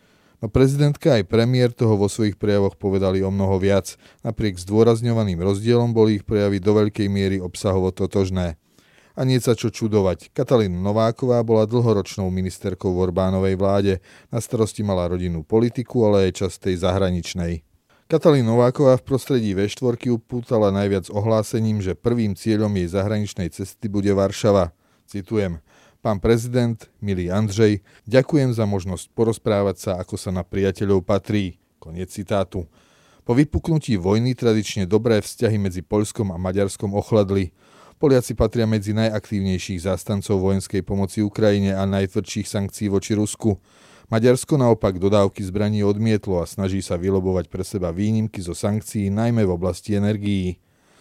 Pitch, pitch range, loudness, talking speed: 105 Hz, 95-115 Hz, -21 LUFS, 140 wpm